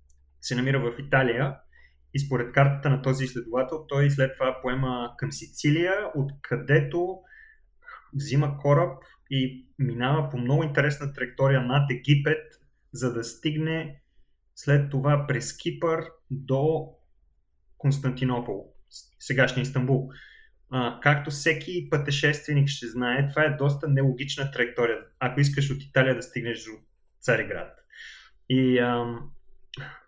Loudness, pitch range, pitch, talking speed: -26 LUFS, 125-150 Hz, 135 Hz, 120 wpm